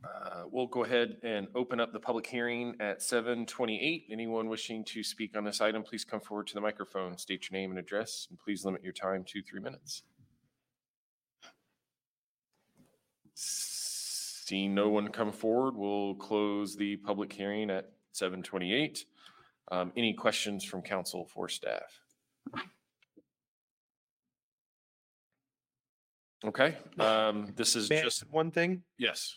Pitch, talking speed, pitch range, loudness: 110 Hz, 140 wpm, 100-120 Hz, -34 LUFS